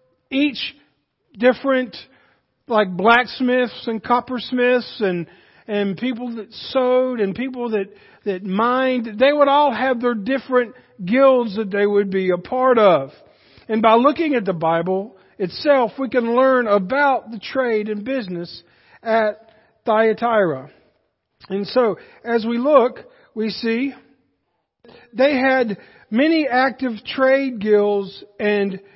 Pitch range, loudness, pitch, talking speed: 205-255 Hz, -19 LUFS, 235 Hz, 125 wpm